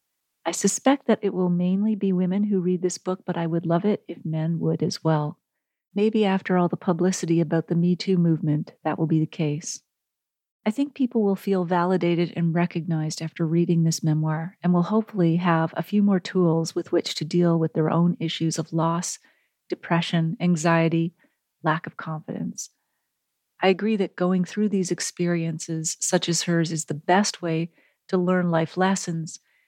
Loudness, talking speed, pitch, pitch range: -24 LUFS, 180 wpm, 175 Hz, 165-185 Hz